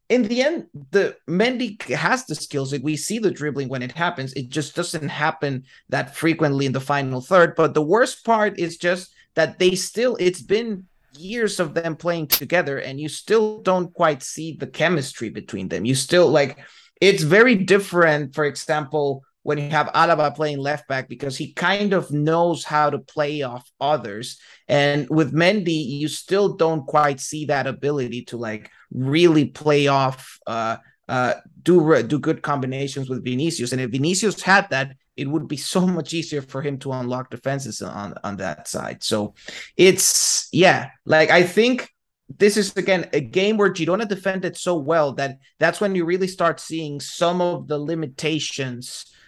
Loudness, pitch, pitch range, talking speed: -21 LUFS, 155 Hz, 140-175 Hz, 180 wpm